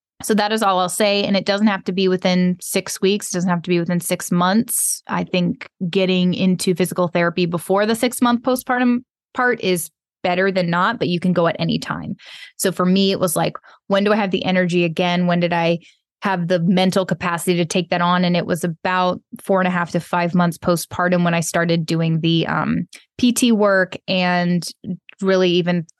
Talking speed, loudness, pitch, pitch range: 215 wpm, -19 LUFS, 185 Hz, 175-195 Hz